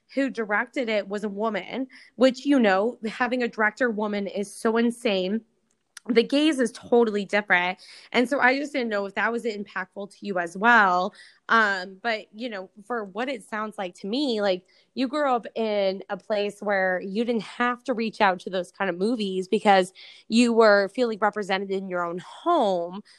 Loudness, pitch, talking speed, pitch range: -24 LUFS, 215 Hz, 195 wpm, 195-240 Hz